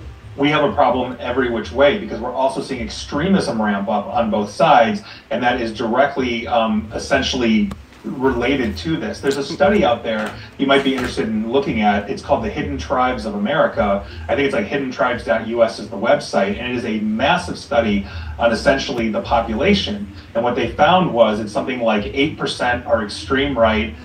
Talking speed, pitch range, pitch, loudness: 185 wpm, 105-140 Hz, 115 Hz, -18 LUFS